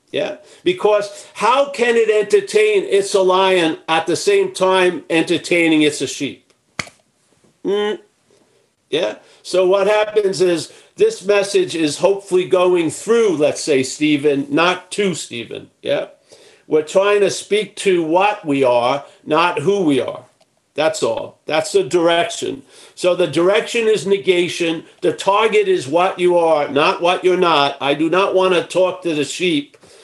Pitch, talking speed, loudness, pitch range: 185 Hz, 155 wpm, -16 LUFS, 165-210 Hz